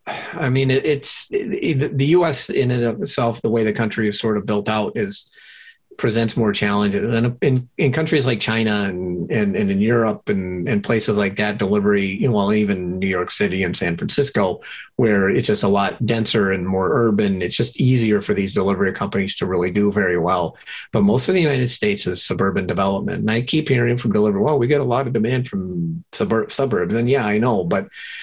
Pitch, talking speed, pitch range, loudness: 115 Hz, 215 wpm, 105-140 Hz, -19 LUFS